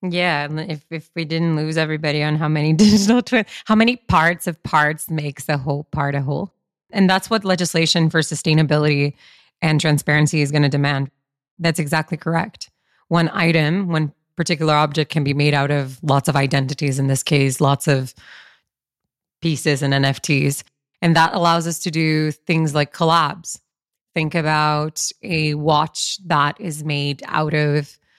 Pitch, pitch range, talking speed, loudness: 155 Hz, 145-165 Hz, 165 wpm, -19 LUFS